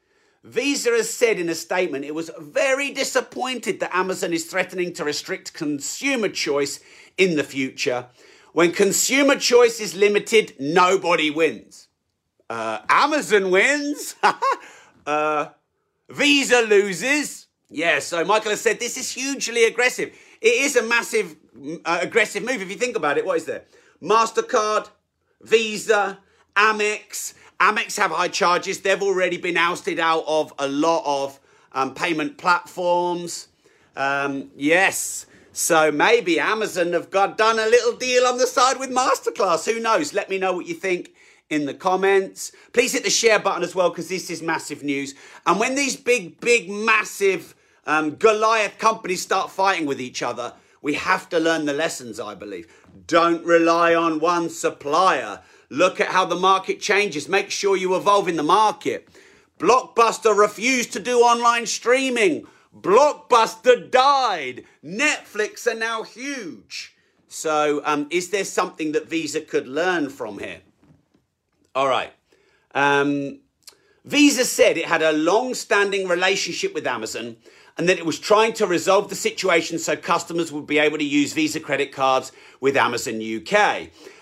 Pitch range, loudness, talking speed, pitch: 165-235 Hz, -20 LUFS, 155 wpm, 195 Hz